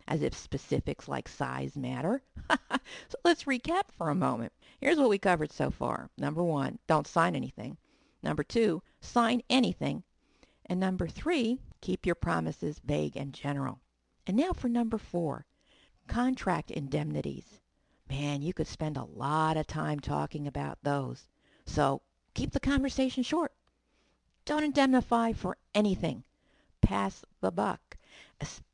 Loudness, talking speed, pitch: -32 LUFS, 140 wpm, 175 Hz